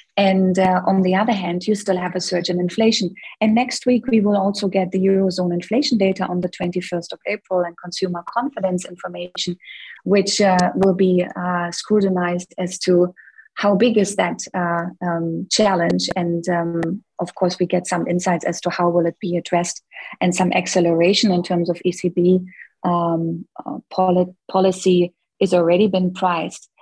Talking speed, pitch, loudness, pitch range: 170 wpm, 180 Hz, -19 LUFS, 175-195 Hz